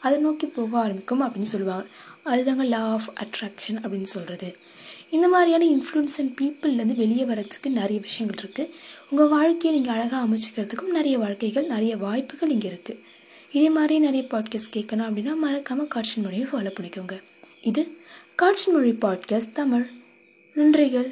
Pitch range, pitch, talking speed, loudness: 215-295 Hz, 245 Hz, 140 wpm, -23 LUFS